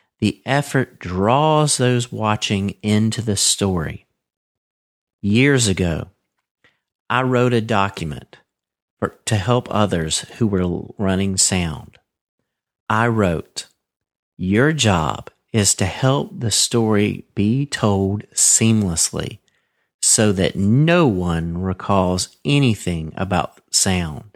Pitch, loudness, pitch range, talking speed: 105 Hz, -18 LUFS, 95-120 Hz, 105 wpm